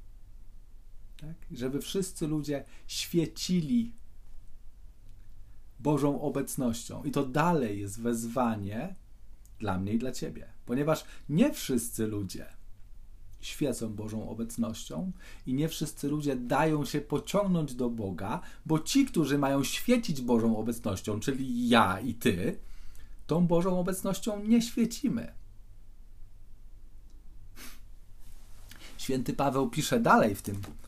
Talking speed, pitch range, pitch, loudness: 105 wpm, 100-150 Hz, 115 Hz, -30 LUFS